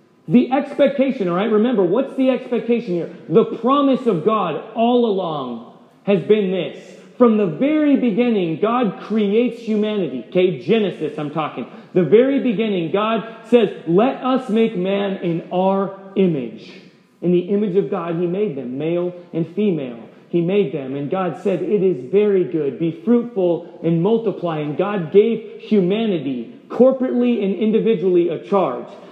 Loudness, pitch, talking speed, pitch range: -19 LUFS, 200 Hz, 155 wpm, 175-225 Hz